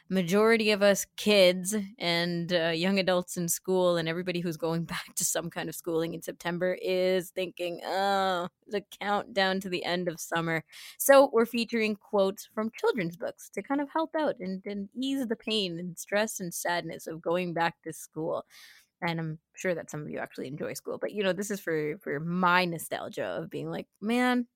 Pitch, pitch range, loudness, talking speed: 185 Hz, 170-210 Hz, -29 LUFS, 200 wpm